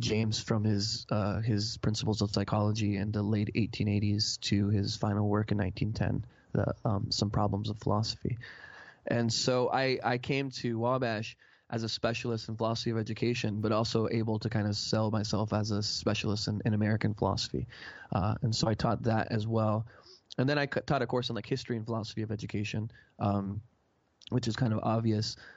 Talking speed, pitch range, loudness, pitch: 190 wpm, 105-115 Hz, -31 LUFS, 110 Hz